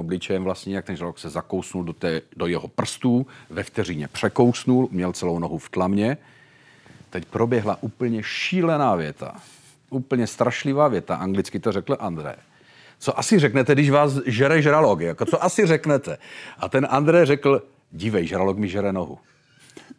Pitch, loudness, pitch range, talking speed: 120 Hz, -22 LUFS, 95-145 Hz, 155 wpm